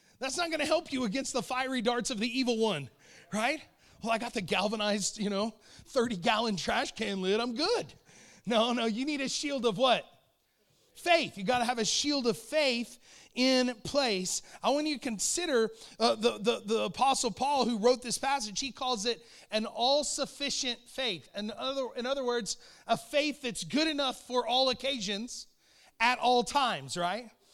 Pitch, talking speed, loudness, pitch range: 245 Hz, 185 wpm, -30 LUFS, 225-265 Hz